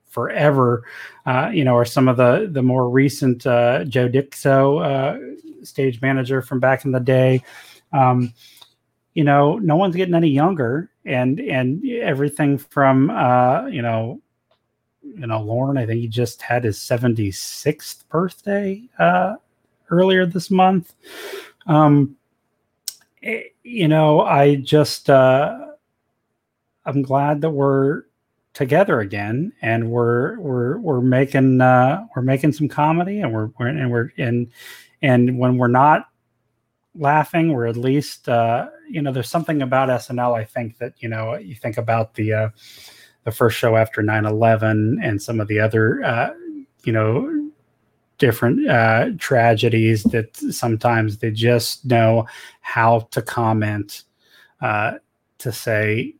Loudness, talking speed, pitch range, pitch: -18 LUFS, 145 wpm, 120-150 Hz, 130 Hz